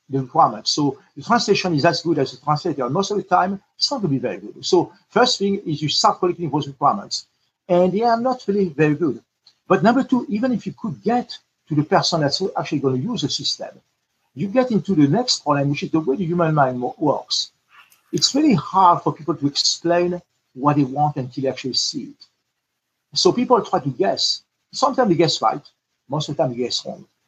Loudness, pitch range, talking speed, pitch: -20 LUFS, 145-200 Hz, 220 wpm, 170 Hz